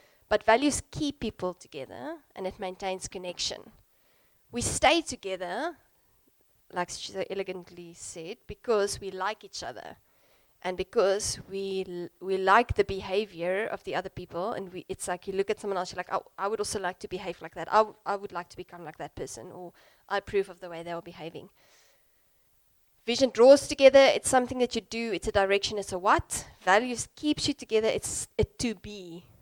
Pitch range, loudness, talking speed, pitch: 180-220 Hz, -28 LUFS, 195 wpm, 195 Hz